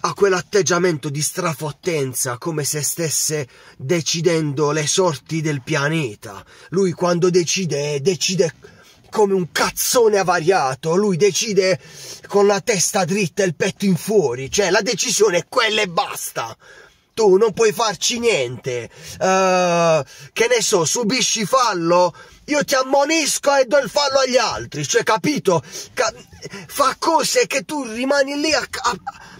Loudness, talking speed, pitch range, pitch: -18 LUFS, 140 wpm, 155-225 Hz, 185 Hz